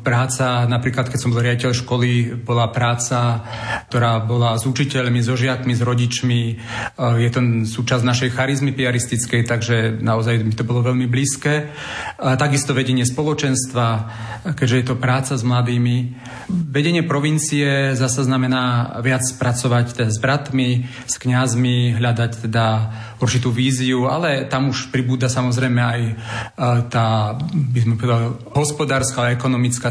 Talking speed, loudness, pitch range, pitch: 130 wpm, -19 LUFS, 120-130 Hz, 125 Hz